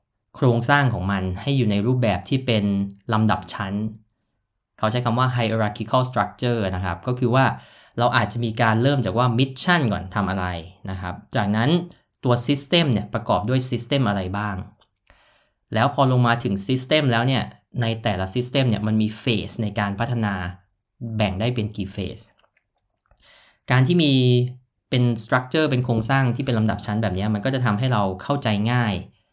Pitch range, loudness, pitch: 105-125 Hz, -22 LUFS, 115 Hz